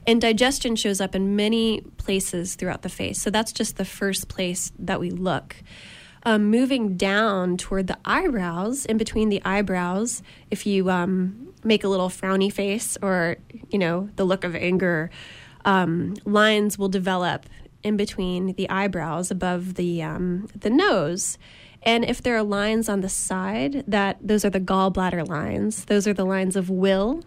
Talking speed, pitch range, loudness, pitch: 170 wpm, 185-215 Hz, -23 LUFS, 195 Hz